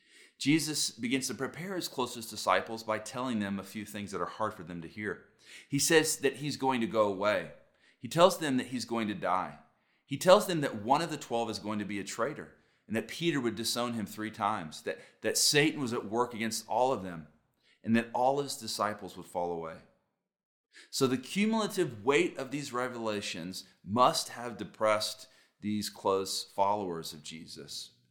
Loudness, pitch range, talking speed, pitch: -31 LUFS, 105-135 Hz, 195 wpm, 115 Hz